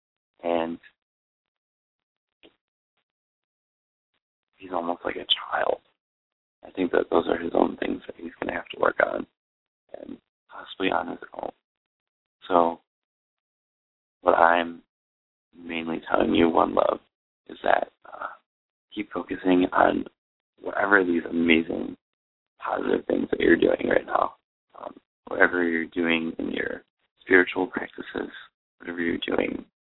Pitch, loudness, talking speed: 85 Hz, -25 LUFS, 125 wpm